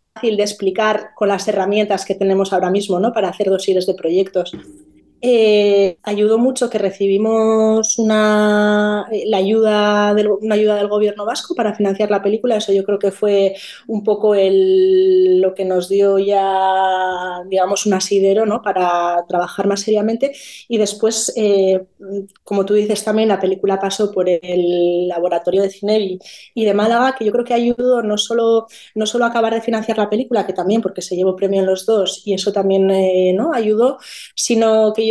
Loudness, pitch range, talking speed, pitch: -16 LUFS, 190-220 Hz, 180 wpm, 205 Hz